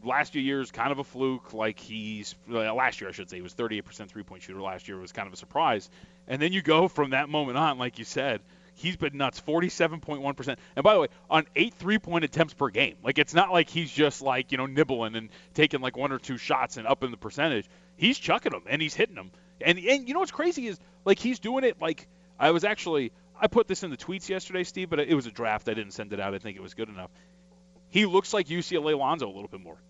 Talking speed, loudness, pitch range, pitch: 260 wpm, -27 LUFS, 125-180 Hz, 155 Hz